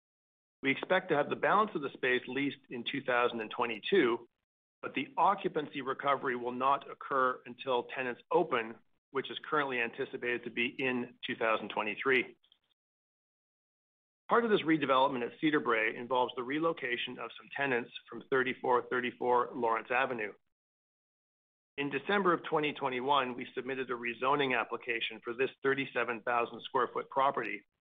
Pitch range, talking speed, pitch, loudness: 120-140 Hz, 135 wpm, 125 Hz, -33 LUFS